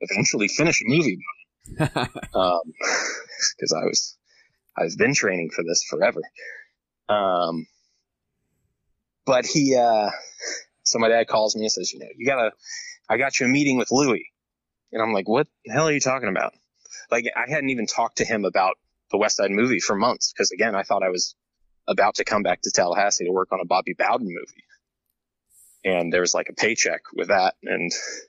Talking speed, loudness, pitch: 180 wpm, -22 LUFS, 130 Hz